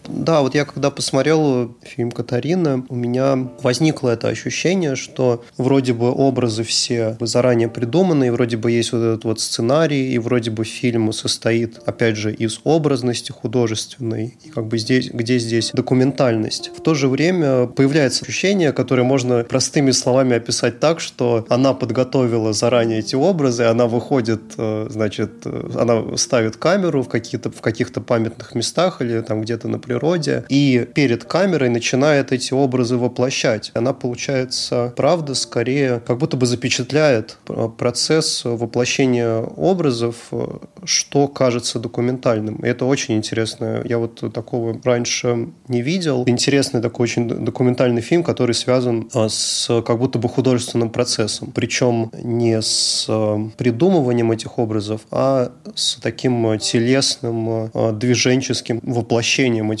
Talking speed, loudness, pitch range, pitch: 135 wpm, -18 LUFS, 115-135 Hz, 125 Hz